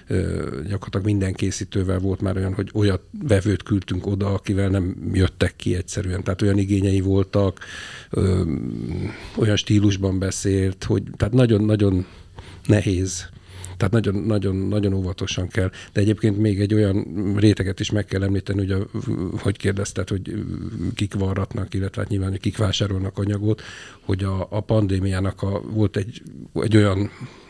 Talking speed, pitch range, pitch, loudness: 140 wpm, 95-105 Hz, 100 Hz, -22 LUFS